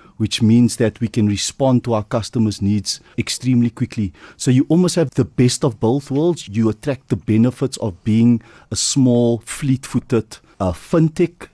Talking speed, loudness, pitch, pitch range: 170 wpm, -18 LUFS, 120 Hz, 110-135 Hz